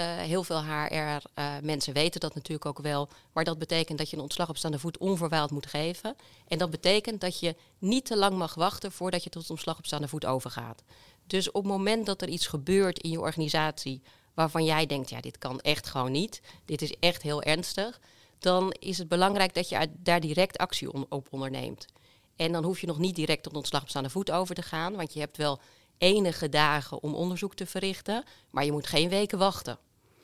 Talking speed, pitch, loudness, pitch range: 215 wpm, 160 Hz, -30 LUFS, 150-180 Hz